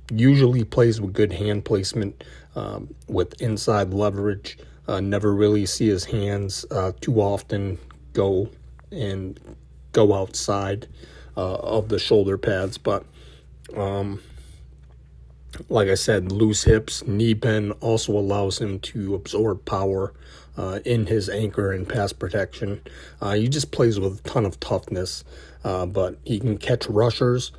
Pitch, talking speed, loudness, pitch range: 100 Hz, 140 wpm, -23 LUFS, 90-110 Hz